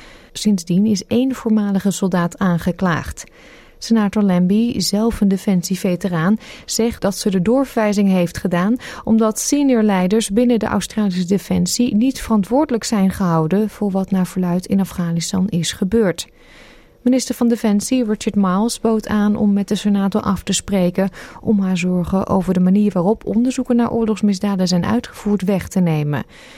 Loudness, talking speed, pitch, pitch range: -17 LUFS, 150 wpm, 205 Hz, 185-225 Hz